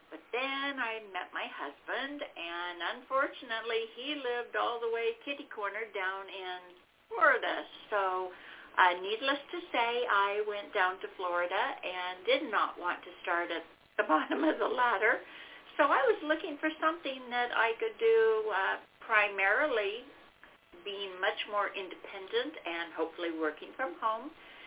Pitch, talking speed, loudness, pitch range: 220 Hz, 150 wpm, -32 LUFS, 185-280 Hz